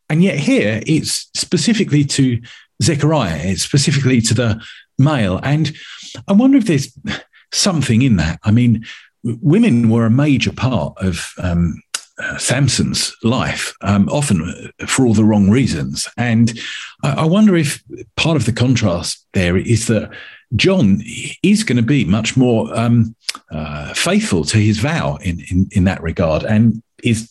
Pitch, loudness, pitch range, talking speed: 115 Hz, -16 LUFS, 100-145 Hz, 155 wpm